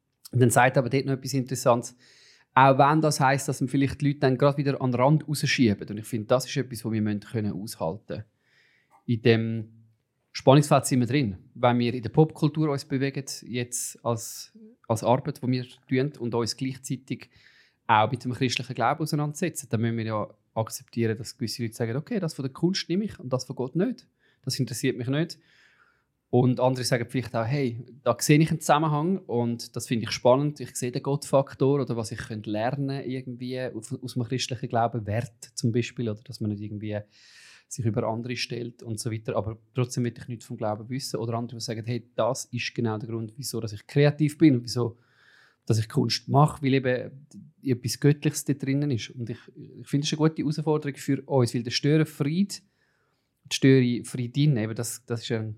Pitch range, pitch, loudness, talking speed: 115-140 Hz, 125 Hz, -26 LUFS, 205 wpm